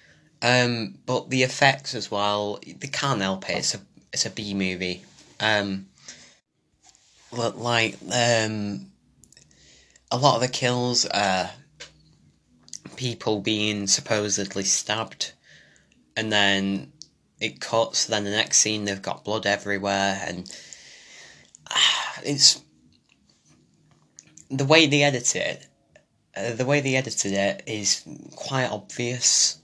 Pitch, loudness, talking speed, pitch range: 105 Hz, -23 LUFS, 120 wpm, 100-125 Hz